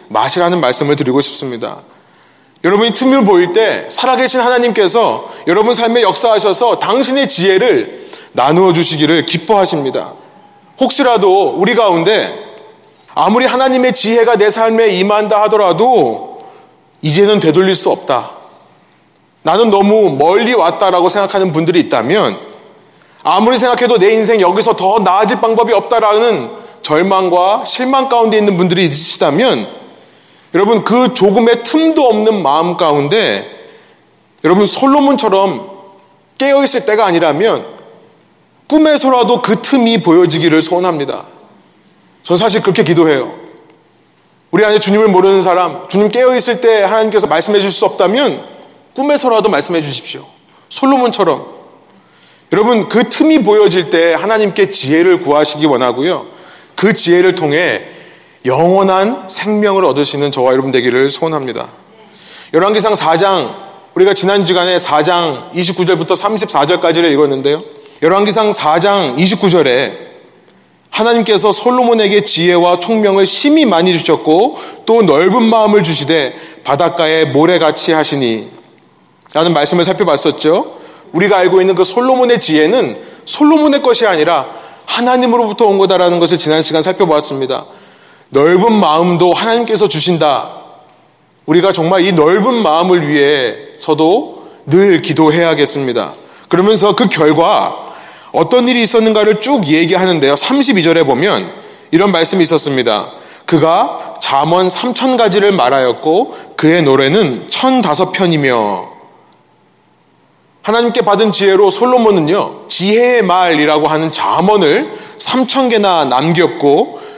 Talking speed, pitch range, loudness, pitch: 300 characters per minute, 165-230 Hz, -11 LUFS, 195 Hz